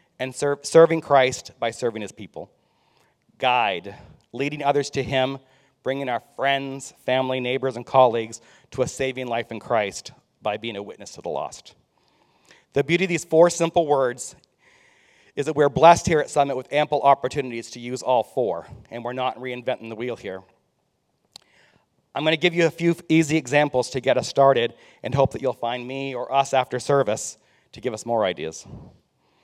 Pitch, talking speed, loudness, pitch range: 135 Hz, 180 wpm, -22 LUFS, 125-145 Hz